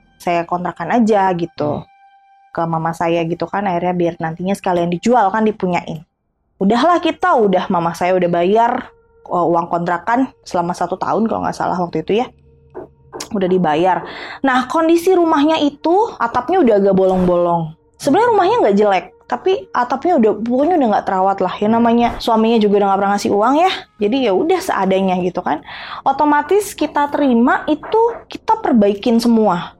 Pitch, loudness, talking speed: 210 Hz, -16 LUFS, 160 wpm